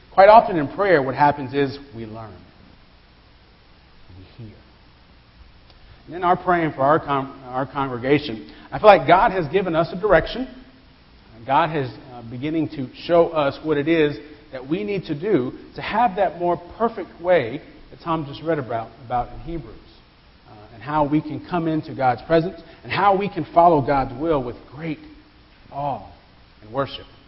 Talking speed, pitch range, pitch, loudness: 180 wpm, 115-165 Hz, 145 Hz, -20 LUFS